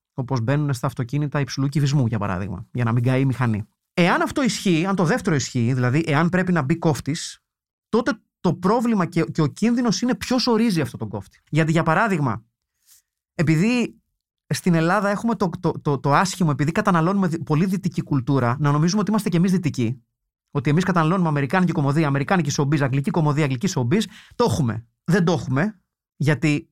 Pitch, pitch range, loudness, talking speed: 160 Hz, 140-190 Hz, -21 LUFS, 180 wpm